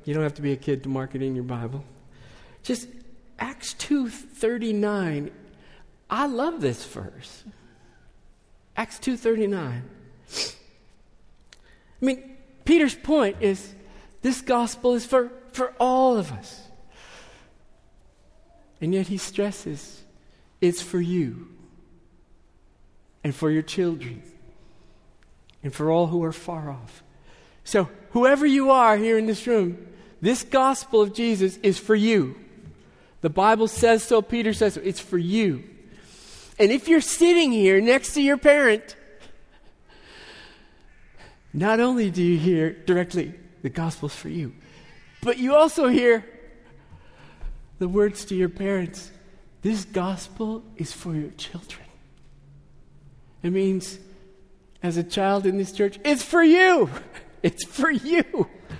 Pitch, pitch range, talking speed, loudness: 200 Hz, 170-240 Hz, 130 wpm, -23 LUFS